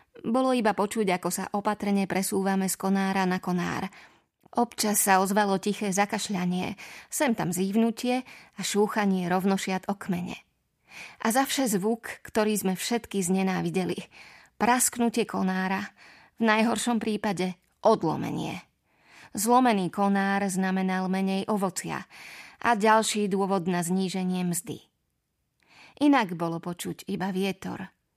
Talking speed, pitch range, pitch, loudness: 115 wpm, 190-220 Hz, 195 Hz, -27 LUFS